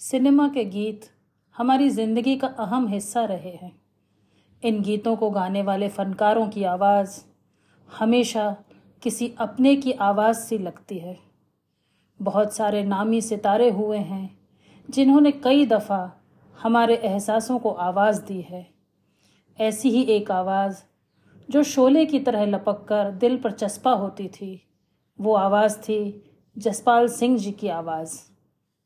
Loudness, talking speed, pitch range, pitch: -22 LUFS, 135 wpm, 195-235 Hz, 210 Hz